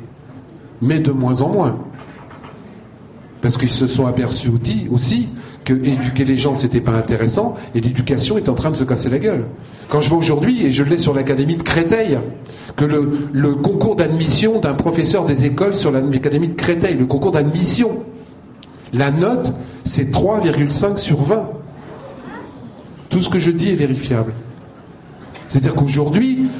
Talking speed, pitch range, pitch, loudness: 165 wpm, 130-165 Hz, 140 Hz, -17 LUFS